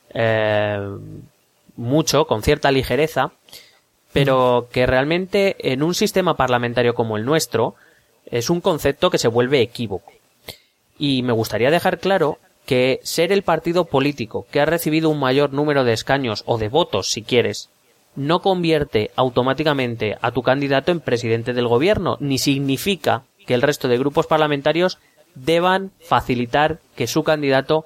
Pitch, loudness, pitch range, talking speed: 140 Hz, -19 LUFS, 125-160 Hz, 145 wpm